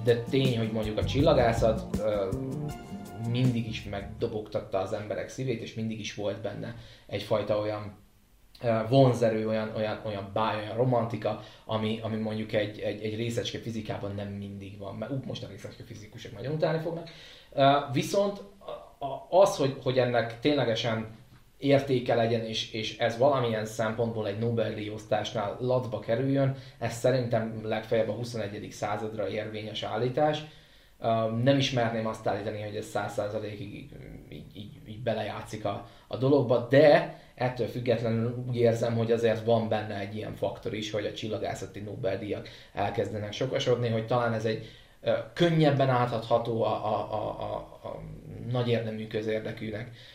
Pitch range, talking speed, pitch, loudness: 110-125 Hz, 140 wpm, 115 Hz, -29 LUFS